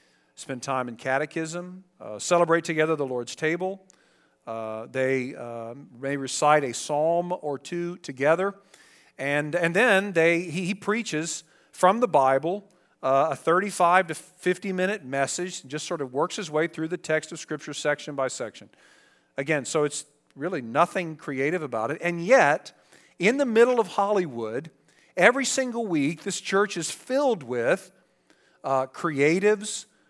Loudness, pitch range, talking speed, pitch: -25 LUFS, 140-185 Hz, 150 wpm, 165 Hz